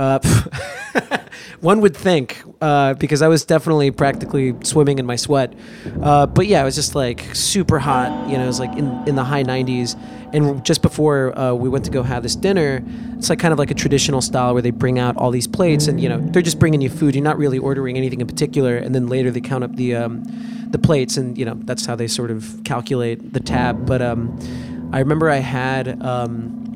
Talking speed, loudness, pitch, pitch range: 230 wpm, -18 LUFS, 135 Hz, 125-150 Hz